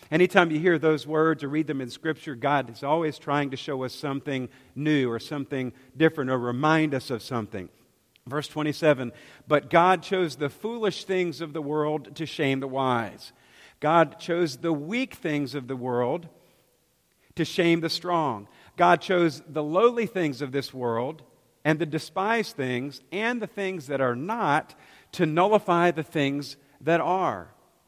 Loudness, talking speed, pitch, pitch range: -26 LUFS, 170 wpm, 150 Hz, 135-170 Hz